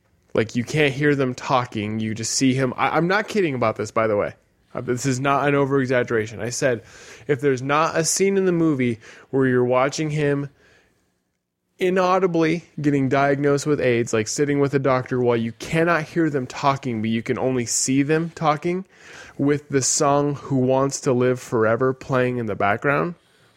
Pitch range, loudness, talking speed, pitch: 125-150 Hz, -21 LUFS, 190 wpm, 135 Hz